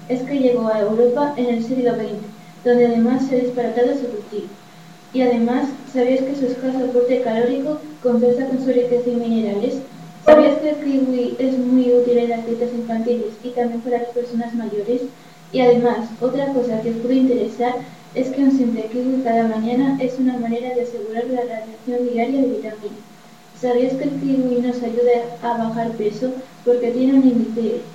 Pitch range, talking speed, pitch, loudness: 230-255 Hz, 180 wpm, 245 Hz, -19 LUFS